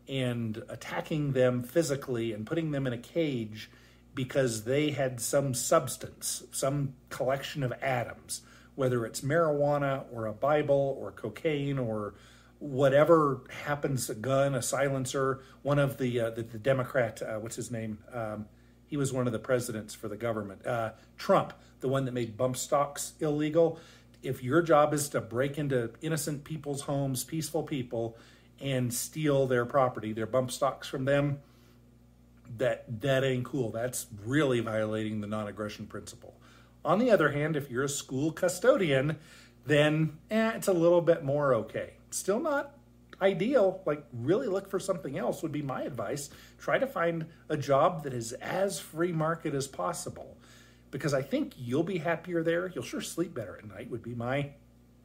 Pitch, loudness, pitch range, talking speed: 135 Hz, -30 LUFS, 120-155 Hz, 165 wpm